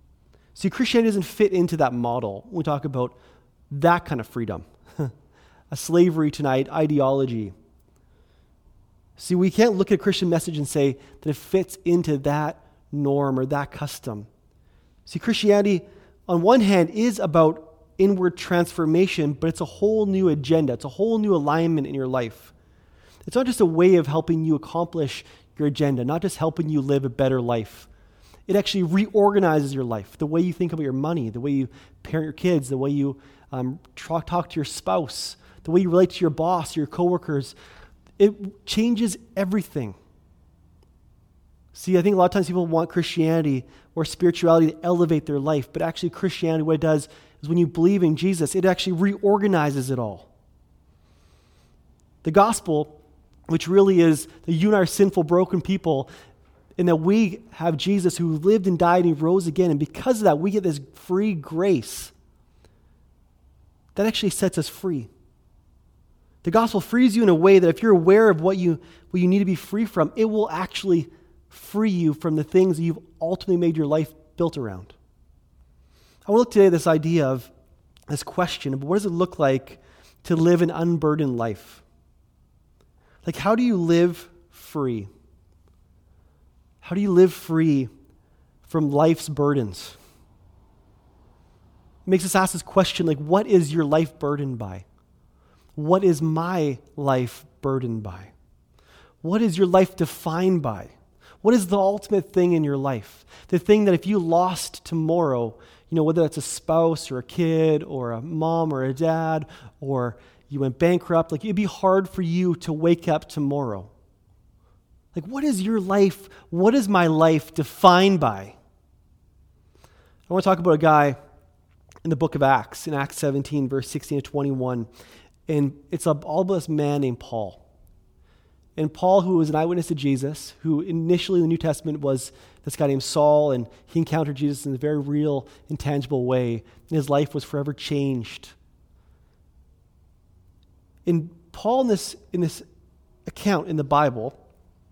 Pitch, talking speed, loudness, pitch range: 155 Hz, 170 wpm, -22 LUFS, 120-180 Hz